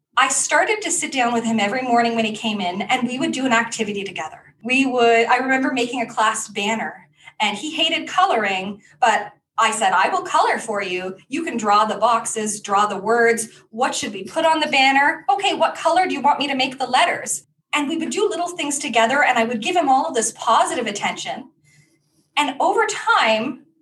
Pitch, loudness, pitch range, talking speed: 240 Hz, -19 LUFS, 215-300 Hz, 215 wpm